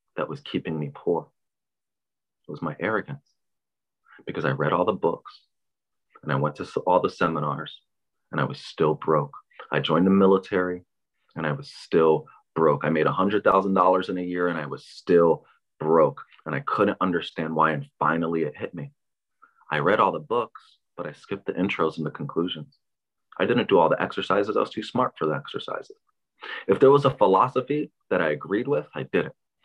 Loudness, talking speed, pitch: -24 LUFS, 190 wpm, 95 Hz